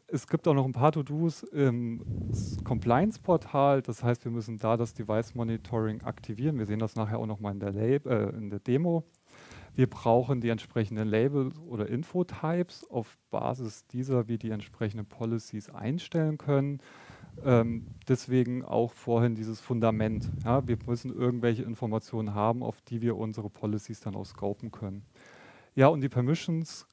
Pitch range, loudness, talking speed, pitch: 110-135 Hz, -30 LUFS, 155 wpm, 115 Hz